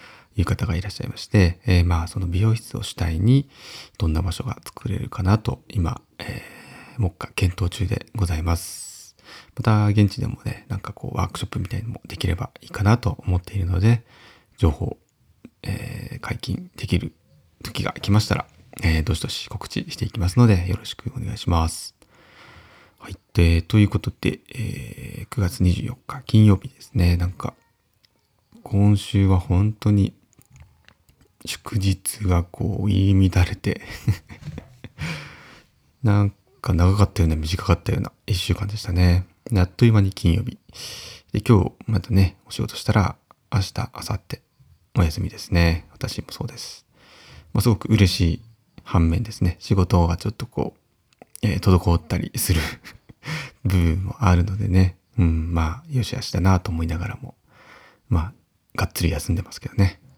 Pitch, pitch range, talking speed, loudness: 100 Hz, 90-115 Hz, 295 characters per minute, -23 LUFS